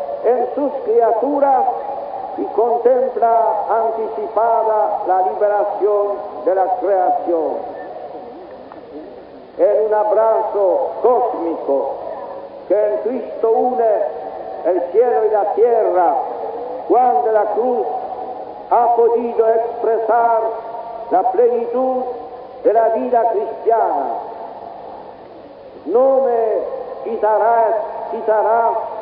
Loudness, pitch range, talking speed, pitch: -17 LUFS, 215-245 Hz, 85 wpm, 230 Hz